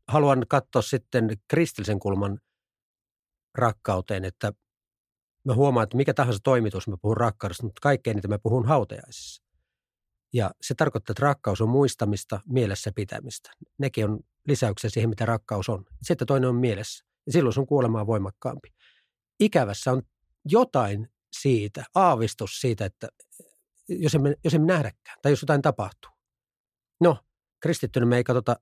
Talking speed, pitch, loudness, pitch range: 145 wpm, 120 Hz, -25 LUFS, 105-140 Hz